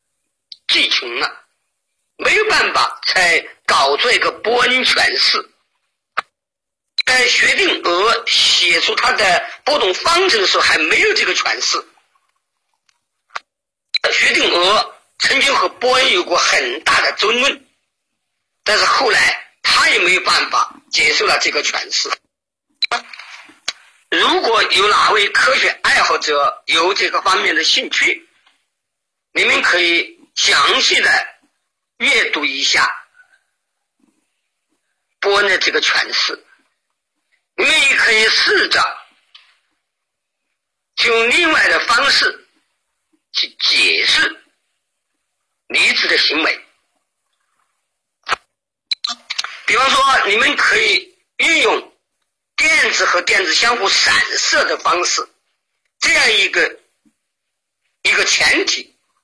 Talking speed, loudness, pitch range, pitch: 160 characters per minute, -13 LUFS, 280-405 Hz, 370 Hz